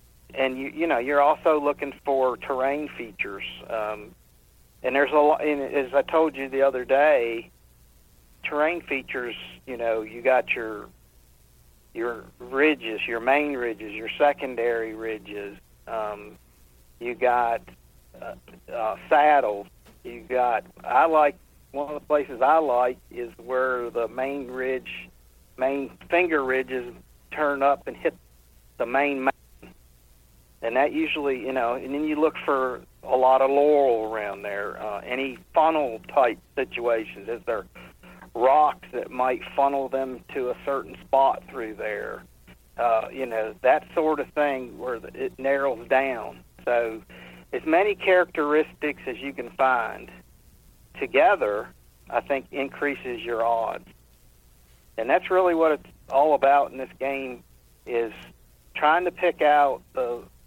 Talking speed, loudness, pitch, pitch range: 140 wpm, -24 LUFS, 130 Hz, 105-145 Hz